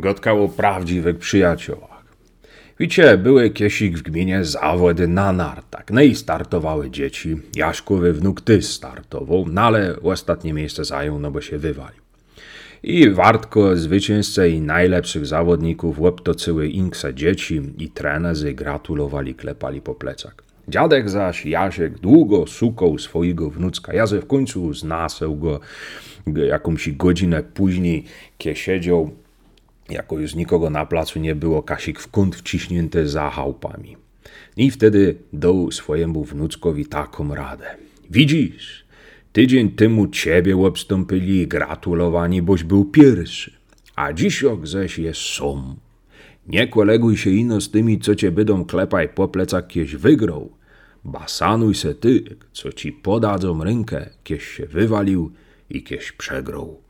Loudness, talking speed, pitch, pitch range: -18 LUFS, 130 wpm, 90 Hz, 80-100 Hz